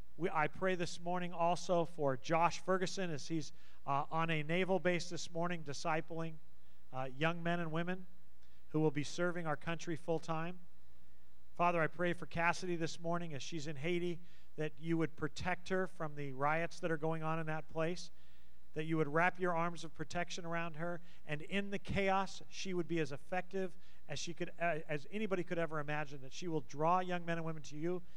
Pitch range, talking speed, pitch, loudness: 155-175 Hz, 200 wpm, 165 Hz, -39 LUFS